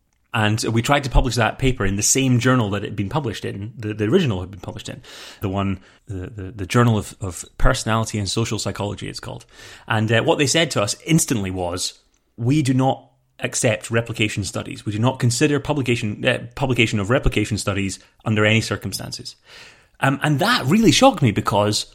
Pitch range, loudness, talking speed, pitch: 105-130 Hz, -20 LUFS, 200 wpm, 110 Hz